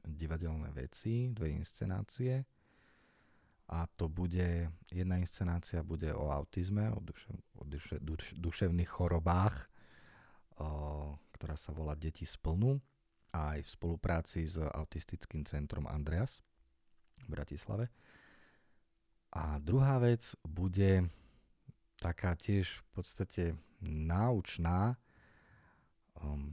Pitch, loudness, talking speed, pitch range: 85 Hz, -38 LUFS, 95 wpm, 75-95 Hz